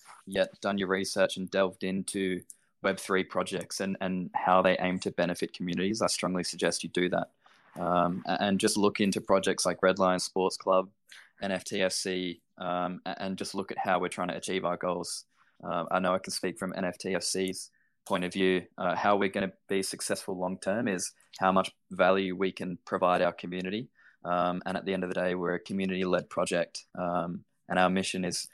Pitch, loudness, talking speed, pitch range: 95 Hz, -30 LUFS, 200 wpm, 90-95 Hz